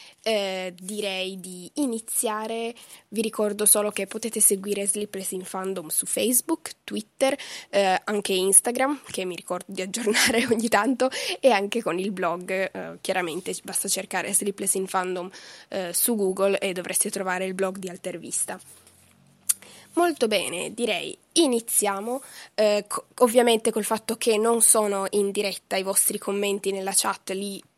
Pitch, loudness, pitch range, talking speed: 200 Hz, -24 LUFS, 190-230 Hz, 145 wpm